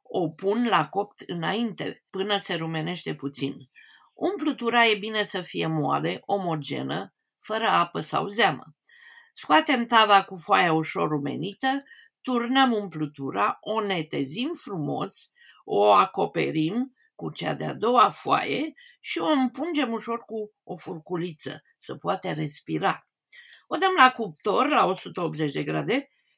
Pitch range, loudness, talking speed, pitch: 165-260 Hz, -25 LUFS, 125 wpm, 205 Hz